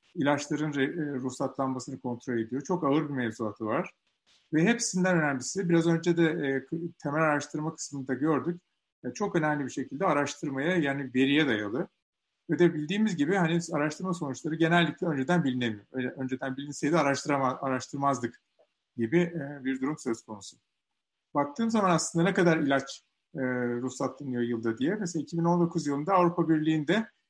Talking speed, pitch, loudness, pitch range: 130 wpm, 145 Hz, -29 LUFS, 135-170 Hz